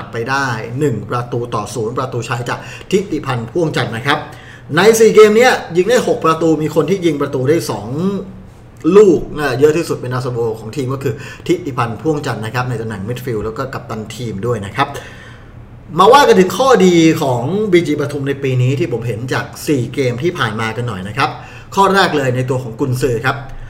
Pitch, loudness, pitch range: 135 Hz, -15 LUFS, 120-155 Hz